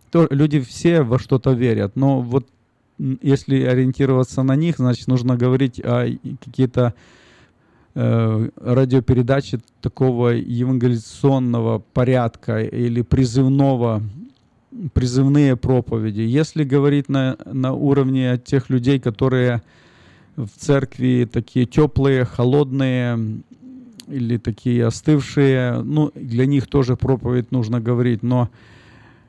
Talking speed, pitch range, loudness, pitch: 100 wpm, 120-135 Hz, -19 LUFS, 130 Hz